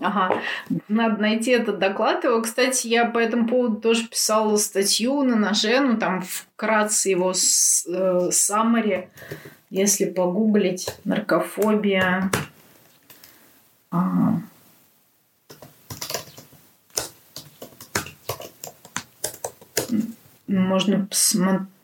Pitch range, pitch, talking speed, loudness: 190-230 Hz, 210 Hz, 75 wpm, -21 LUFS